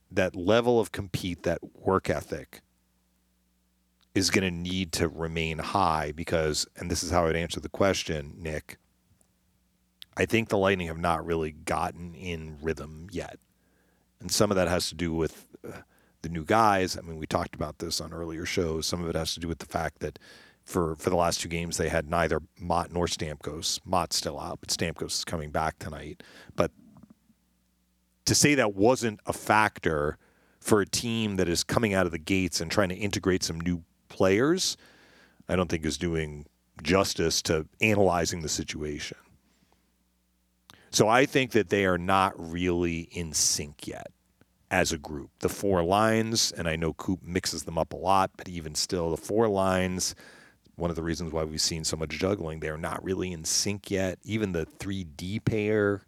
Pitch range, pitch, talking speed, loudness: 80-95 Hz, 85 Hz, 185 wpm, -28 LUFS